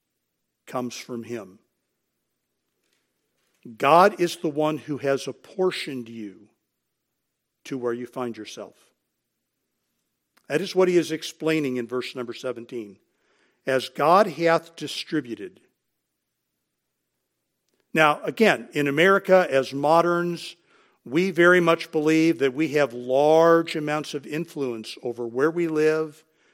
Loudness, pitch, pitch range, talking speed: -23 LUFS, 150 Hz, 125-165 Hz, 115 wpm